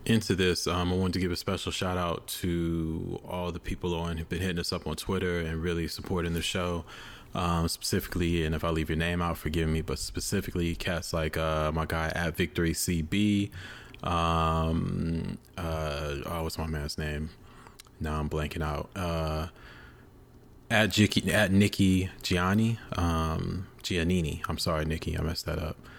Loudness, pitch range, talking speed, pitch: -30 LUFS, 80-95 Hz, 175 wpm, 85 Hz